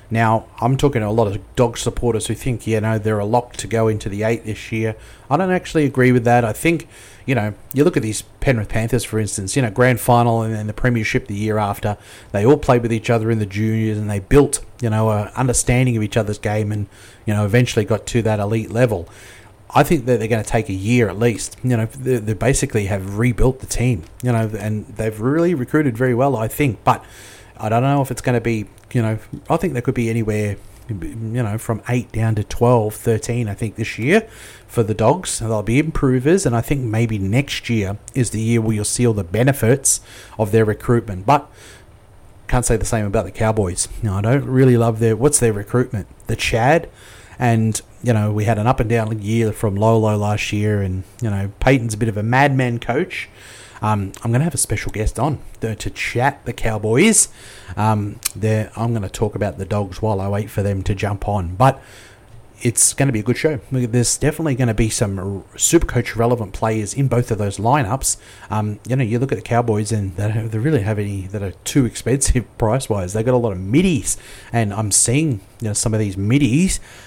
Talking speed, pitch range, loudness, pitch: 230 wpm, 105-125 Hz, -19 LUFS, 115 Hz